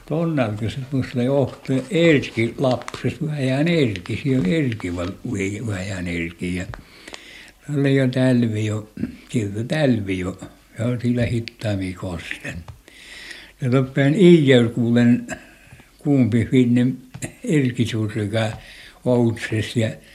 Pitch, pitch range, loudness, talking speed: 120 Hz, 110-135 Hz, -21 LUFS, 105 wpm